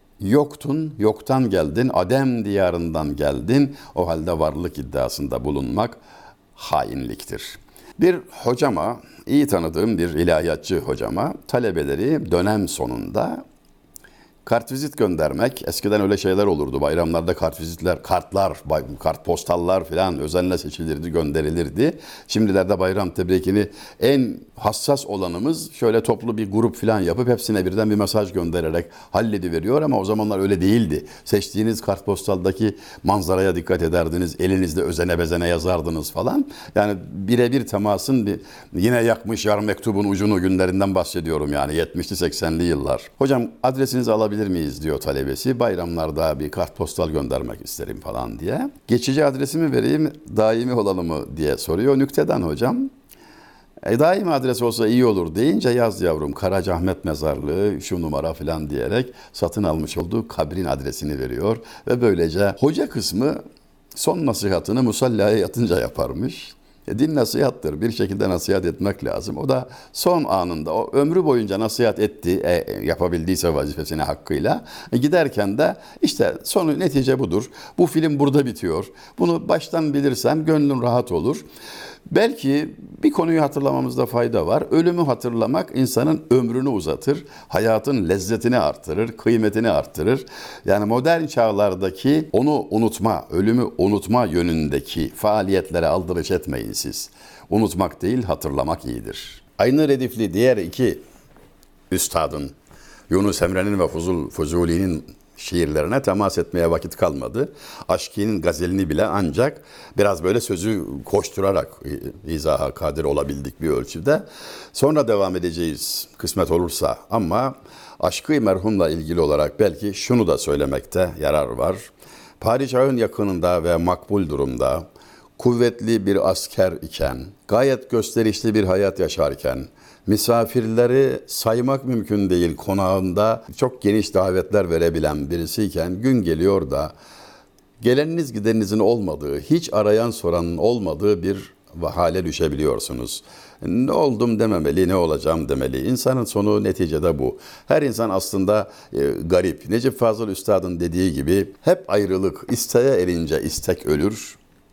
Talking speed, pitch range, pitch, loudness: 125 wpm, 90-120 Hz, 105 Hz, -21 LUFS